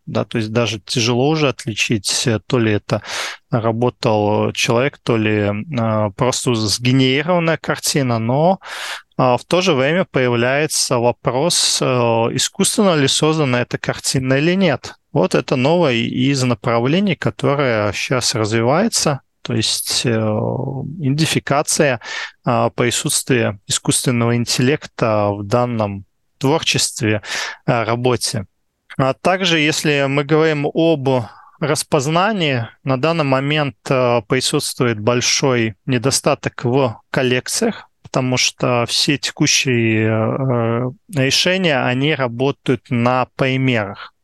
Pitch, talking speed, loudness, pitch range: 130 Hz, 105 wpm, -17 LUFS, 115-150 Hz